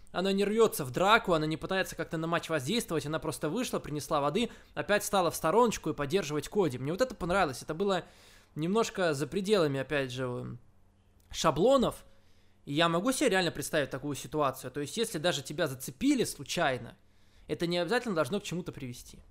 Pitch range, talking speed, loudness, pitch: 145-195 Hz, 180 wpm, -30 LUFS, 160 Hz